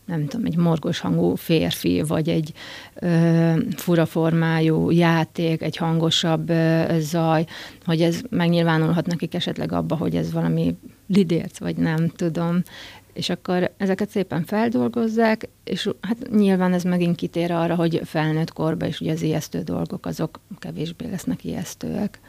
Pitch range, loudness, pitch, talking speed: 160-175 Hz, -22 LUFS, 165 Hz, 145 wpm